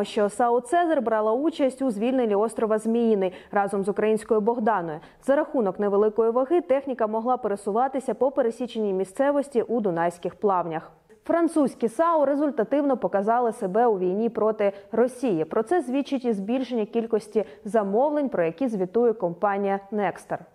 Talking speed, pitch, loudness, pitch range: 135 wpm, 225 Hz, -24 LUFS, 205-260 Hz